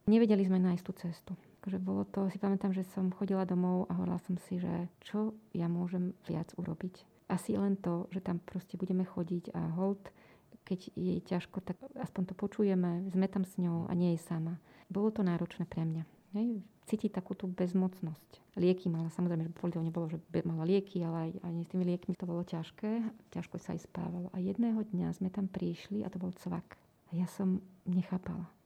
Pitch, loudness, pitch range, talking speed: 185 Hz, -36 LUFS, 175-195 Hz, 195 wpm